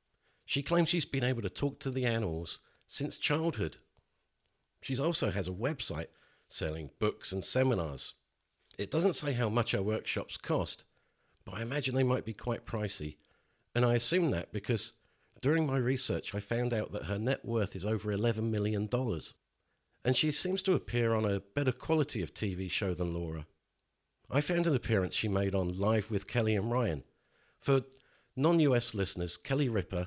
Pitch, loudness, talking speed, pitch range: 115 Hz, -32 LUFS, 175 wpm, 100-135 Hz